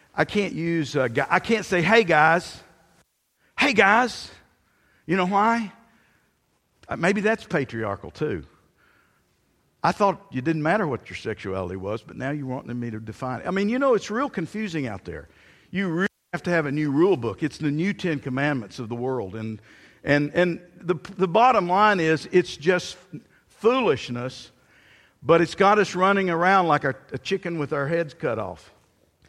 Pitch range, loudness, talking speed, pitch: 130-190 Hz, -23 LUFS, 180 wpm, 165 Hz